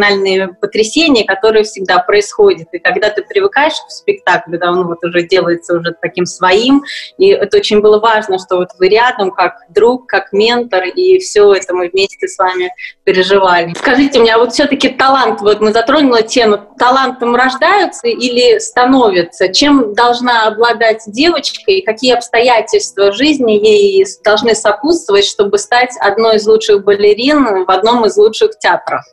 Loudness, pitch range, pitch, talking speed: -10 LUFS, 195-295 Hz, 230 Hz, 160 wpm